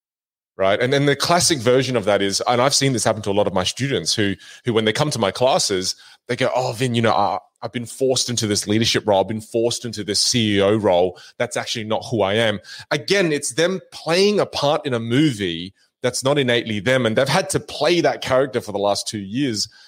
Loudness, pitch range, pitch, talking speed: -19 LUFS, 105-140 Hz, 120 Hz, 240 wpm